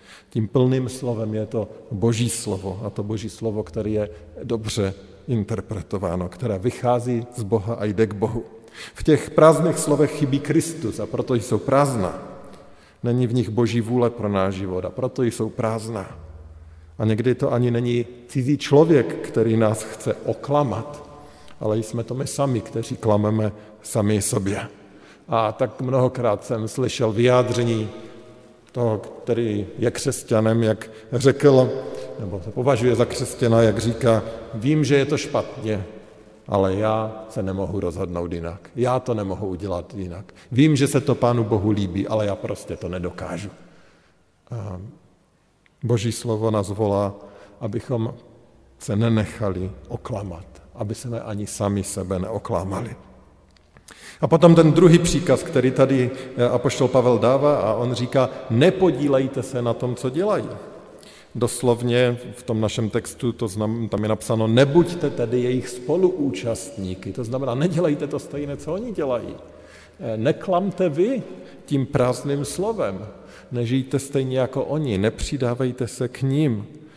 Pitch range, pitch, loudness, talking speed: 105-130 Hz, 115 Hz, -22 LUFS, 140 wpm